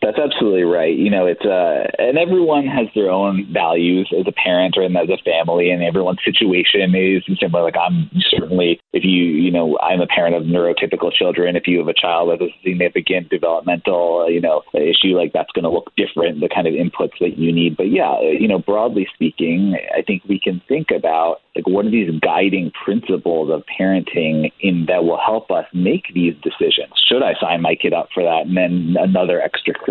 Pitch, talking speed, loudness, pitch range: 90 Hz, 210 wpm, -16 LUFS, 85-95 Hz